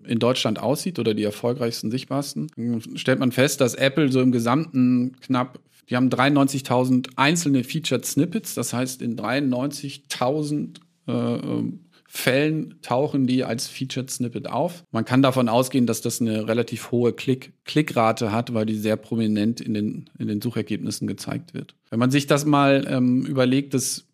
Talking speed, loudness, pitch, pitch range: 160 wpm, -23 LUFS, 125 Hz, 115-140 Hz